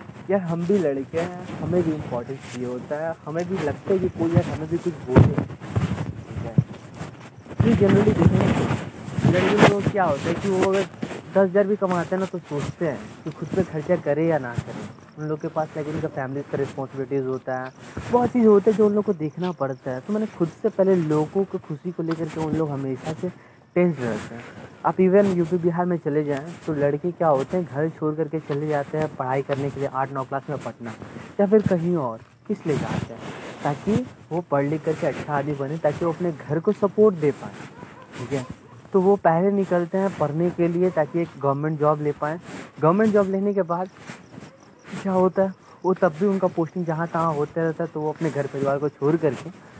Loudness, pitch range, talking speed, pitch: -23 LUFS, 140-180 Hz, 225 wpm, 160 Hz